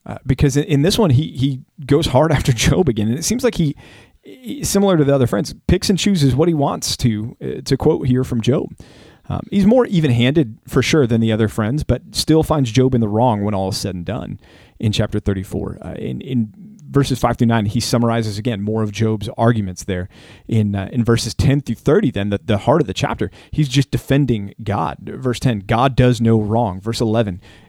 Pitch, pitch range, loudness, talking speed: 120 Hz, 110-140 Hz, -17 LUFS, 225 wpm